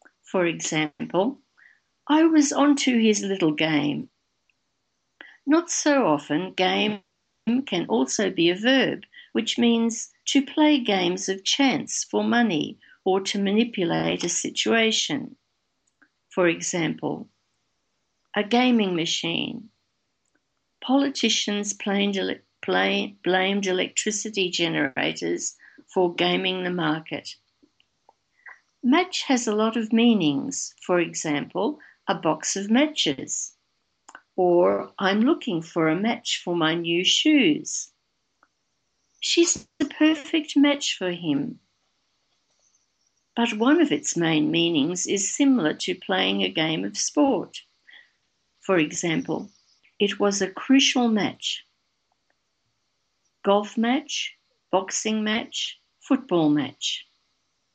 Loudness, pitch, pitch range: -23 LUFS, 210 Hz, 175-265 Hz